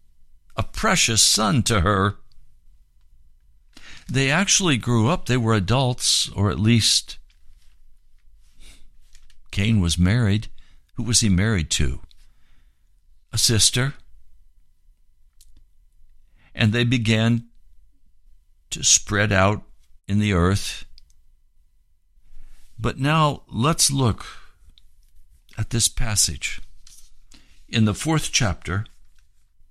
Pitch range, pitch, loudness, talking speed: 70-115 Hz, 90 Hz, -20 LUFS, 90 wpm